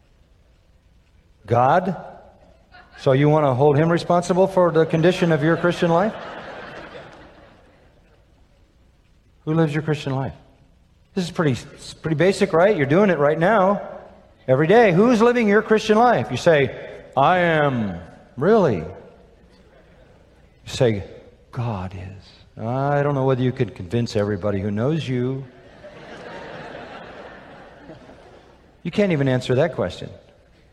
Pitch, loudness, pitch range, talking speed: 150 Hz, -19 LUFS, 120-180 Hz, 125 wpm